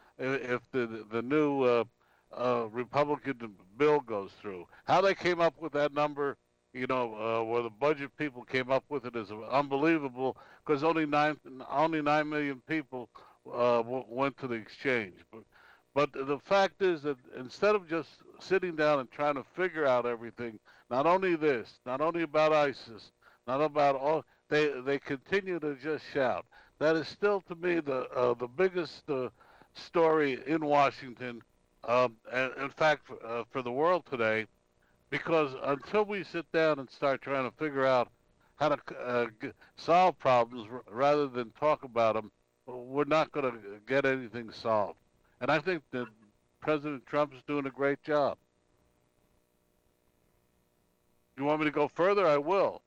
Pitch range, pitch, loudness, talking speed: 120-150 Hz, 135 Hz, -31 LUFS, 165 wpm